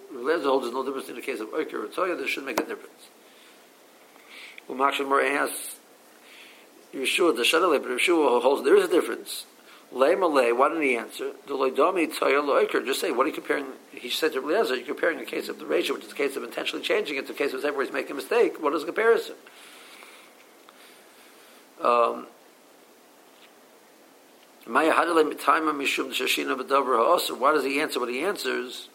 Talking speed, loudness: 170 wpm, -25 LUFS